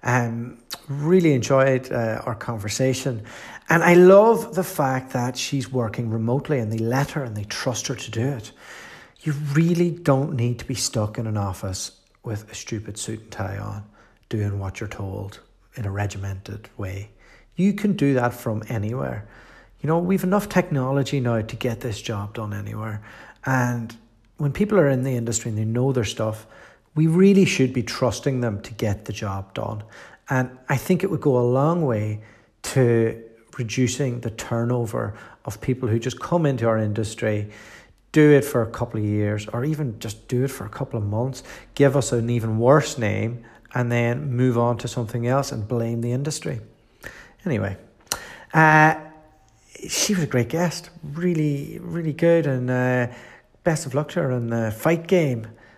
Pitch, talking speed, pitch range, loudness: 120 Hz, 185 wpm, 110-140 Hz, -22 LUFS